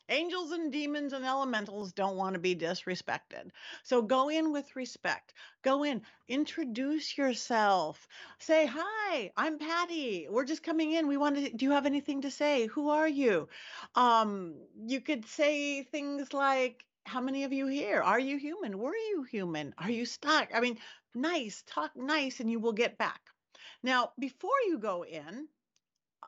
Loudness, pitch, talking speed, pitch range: -32 LUFS, 275 Hz, 170 wpm, 235-300 Hz